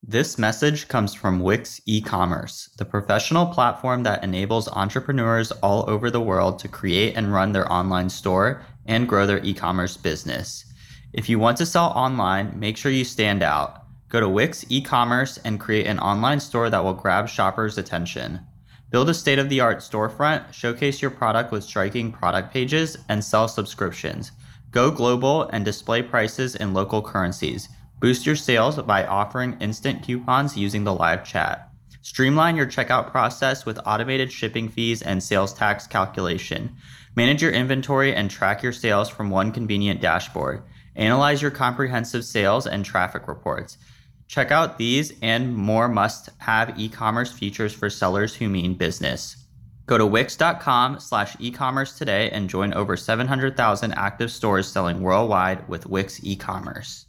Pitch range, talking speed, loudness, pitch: 100-125 Hz, 150 wpm, -22 LUFS, 115 Hz